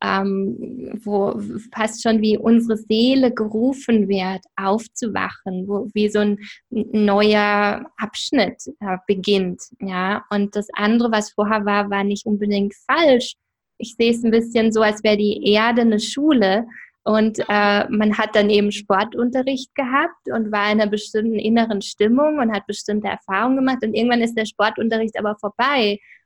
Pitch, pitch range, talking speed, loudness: 215 Hz, 205-230 Hz, 155 wpm, -19 LUFS